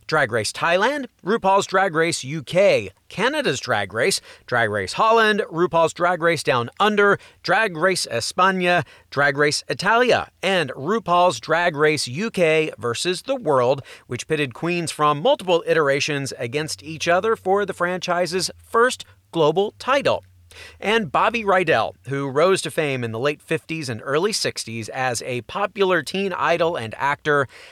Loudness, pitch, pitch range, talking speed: -20 LUFS, 165 Hz, 145-190 Hz, 145 wpm